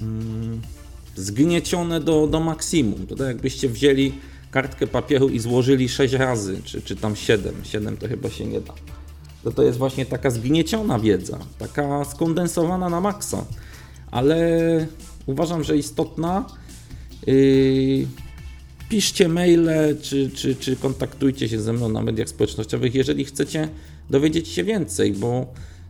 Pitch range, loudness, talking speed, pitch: 110-155 Hz, -22 LUFS, 130 wpm, 135 Hz